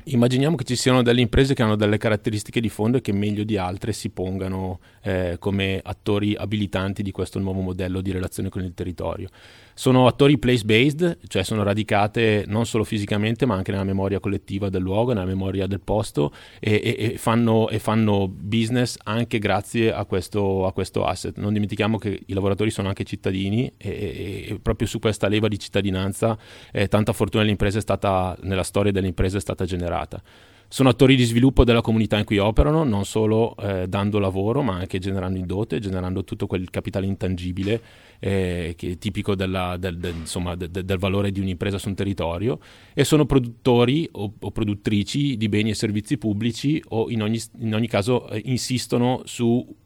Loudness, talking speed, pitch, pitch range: -23 LUFS, 185 wpm, 105 Hz, 95-115 Hz